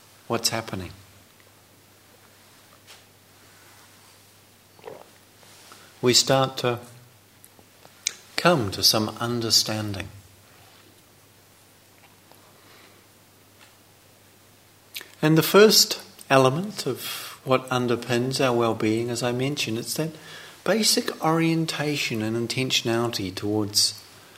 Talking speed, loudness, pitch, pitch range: 70 wpm, -22 LUFS, 110 Hz, 100-125 Hz